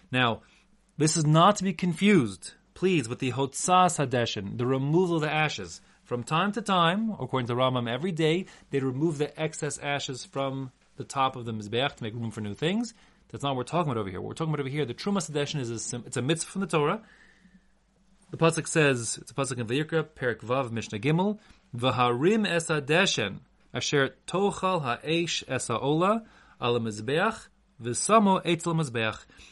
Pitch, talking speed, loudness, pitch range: 150 Hz, 185 wpm, -27 LUFS, 125-180 Hz